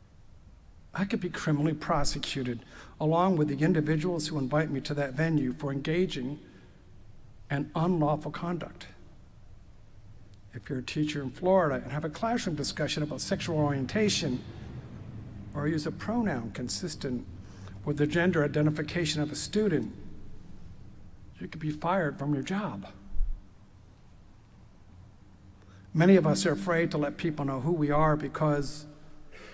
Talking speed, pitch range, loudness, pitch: 135 wpm, 100-160 Hz, -29 LUFS, 145 Hz